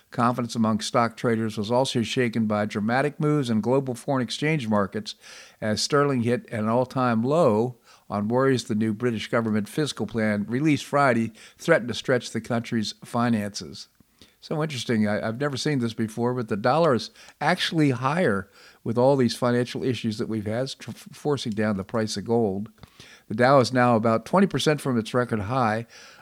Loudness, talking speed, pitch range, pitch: -24 LUFS, 175 wpm, 110-130 Hz, 120 Hz